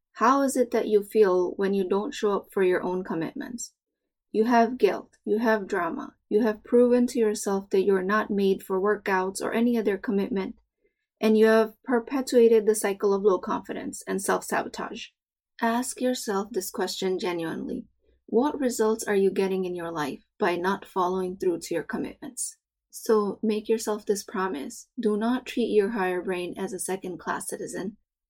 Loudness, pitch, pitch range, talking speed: -26 LUFS, 215 Hz, 190-235 Hz, 180 wpm